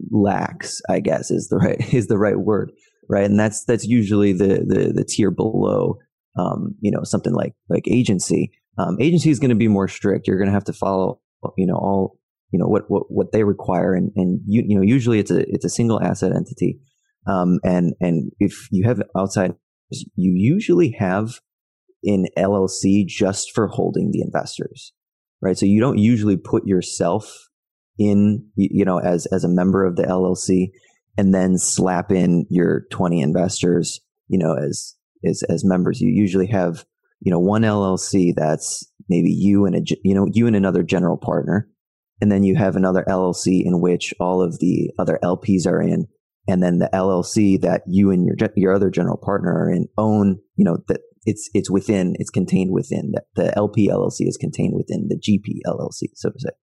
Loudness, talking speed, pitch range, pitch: -19 LUFS, 195 wpm, 90-105 Hz, 95 Hz